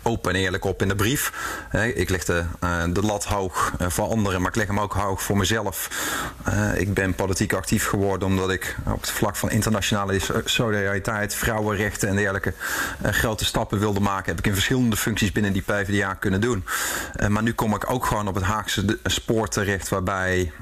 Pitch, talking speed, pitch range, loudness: 100 Hz, 190 wpm, 95-110 Hz, -23 LUFS